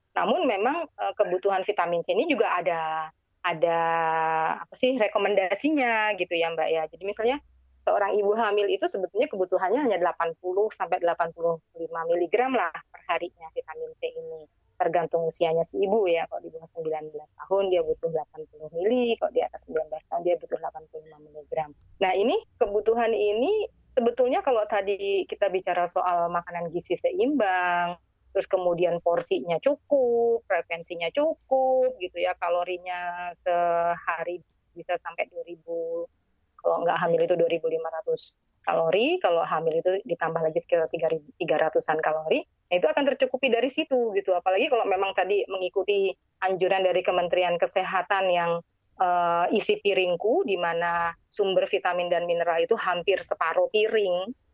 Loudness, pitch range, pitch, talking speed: -26 LUFS, 170-230 Hz, 180 Hz, 140 wpm